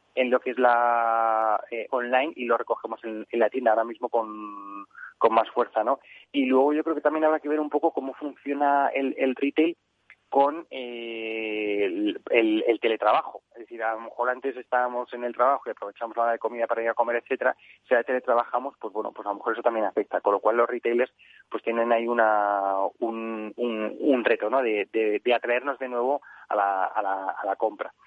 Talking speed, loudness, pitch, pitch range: 220 wpm, -26 LUFS, 120 Hz, 110-135 Hz